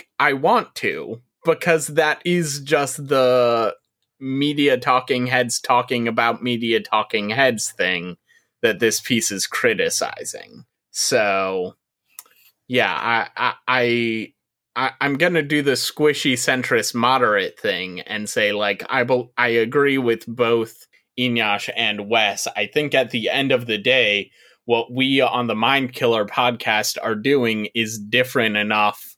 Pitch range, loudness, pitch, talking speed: 110-135 Hz, -19 LUFS, 120 Hz, 140 wpm